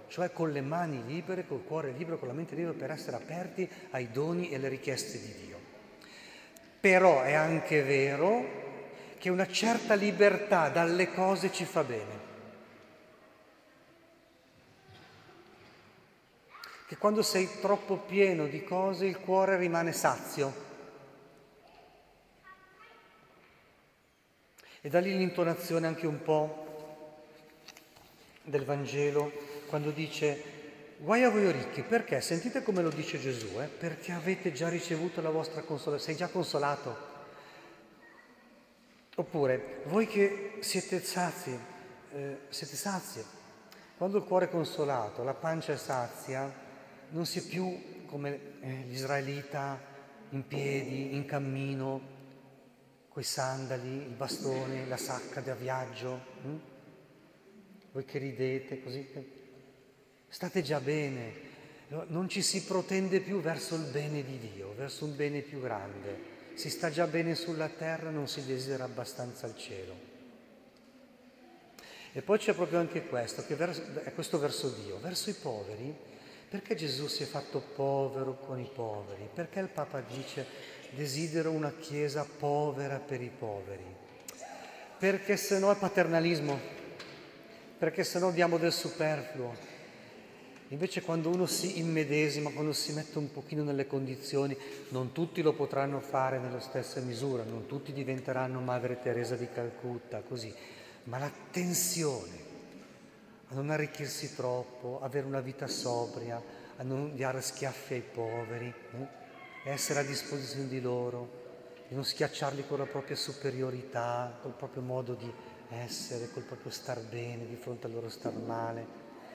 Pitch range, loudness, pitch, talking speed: 135-170 Hz, -34 LUFS, 145 Hz, 135 wpm